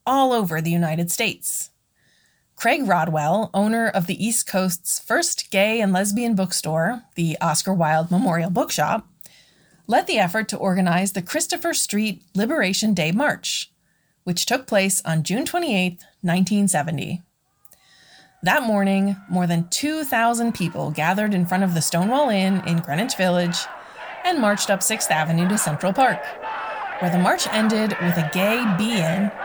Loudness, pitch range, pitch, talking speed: -21 LUFS, 175-220 Hz, 195 Hz, 150 wpm